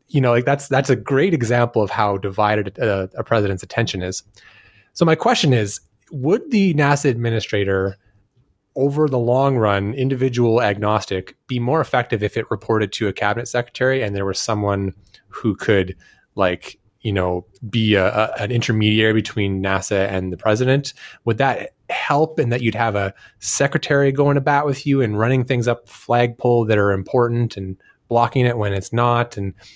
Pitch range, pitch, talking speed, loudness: 100-130 Hz, 115 Hz, 175 wpm, -19 LUFS